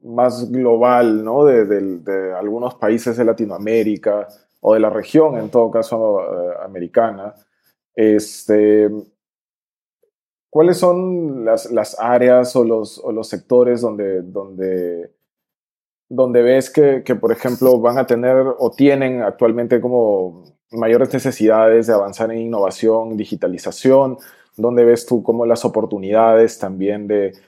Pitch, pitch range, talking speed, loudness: 115 Hz, 105-125 Hz, 130 wpm, -16 LUFS